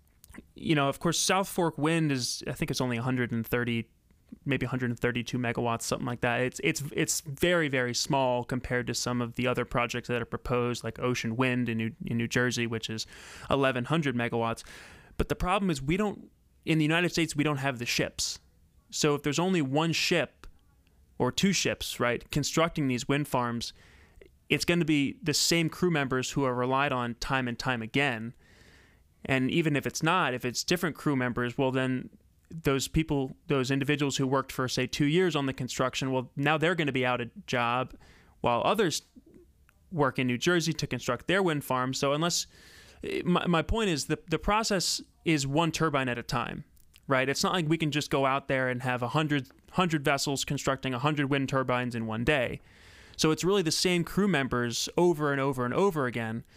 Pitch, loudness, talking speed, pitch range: 135 Hz, -29 LUFS, 205 wpm, 120-155 Hz